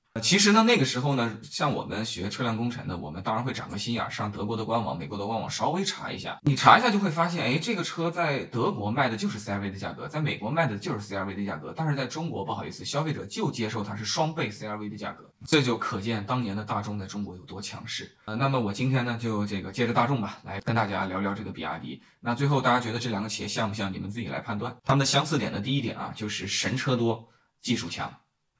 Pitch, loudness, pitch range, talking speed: 115 Hz, -28 LUFS, 105-135 Hz, 395 characters per minute